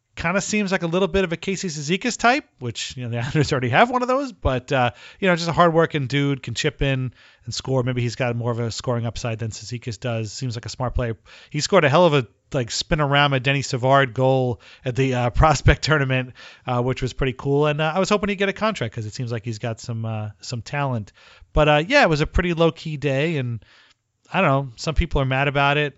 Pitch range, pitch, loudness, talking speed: 120-160 Hz, 135 Hz, -21 LUFS, 260 wpm